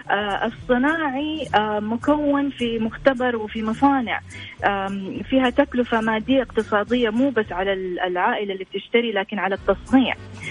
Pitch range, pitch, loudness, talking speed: 200-265 Hz, 230 Hz, -22 LUFS, 110 wpm